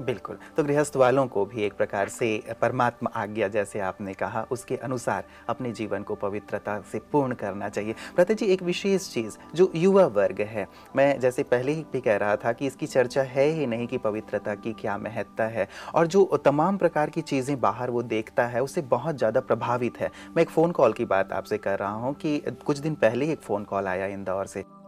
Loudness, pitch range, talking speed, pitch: -26 LUFS, 105-150 Hz, 210 wpm, 120 Hz